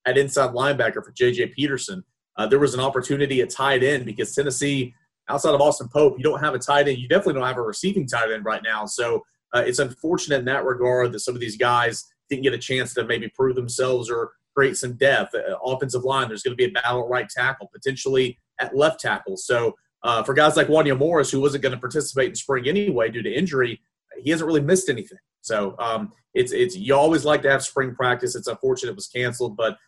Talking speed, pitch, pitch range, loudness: 235 wpm, 135 Hz, 125-150 Hz, -22 LUFS